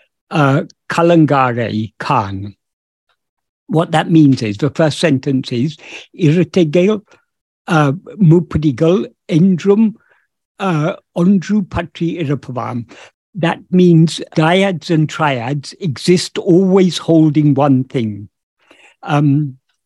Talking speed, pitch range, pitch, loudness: 80 wpm, 140-180 Hz, 160 Hz, -14 LUFS